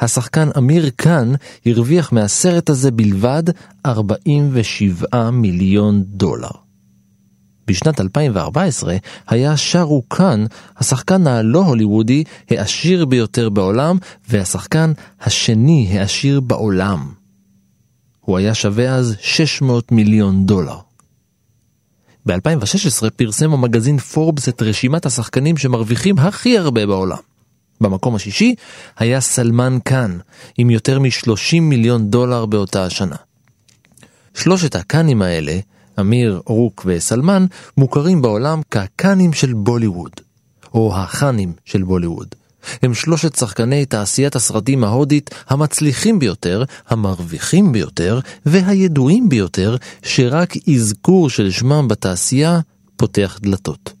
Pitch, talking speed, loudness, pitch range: 120 Hz, 100 wpm, -15 LUFS, 105-150 Hz